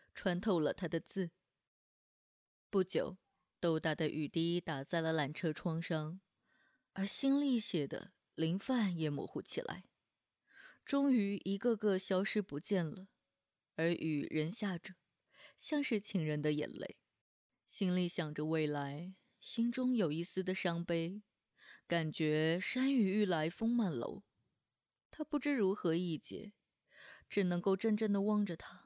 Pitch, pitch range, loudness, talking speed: 185 Hz, 160-210 Hz, -37 LUFS, 195 characters per minute